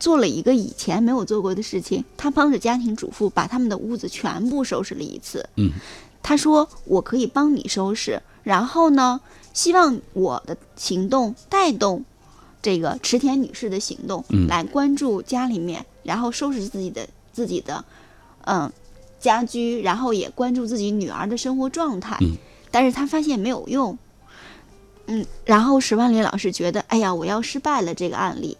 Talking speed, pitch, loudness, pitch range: 260 characters per minute, 235 Hz, -22 LUFS, 200-270 Hz